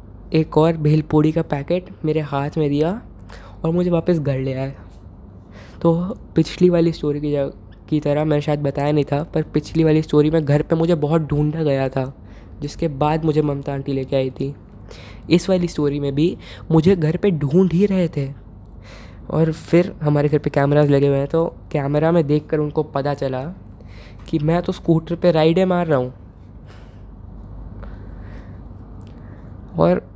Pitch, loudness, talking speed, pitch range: 150 Hz, -19 LUFS, 175 wpm, 125-160 Hz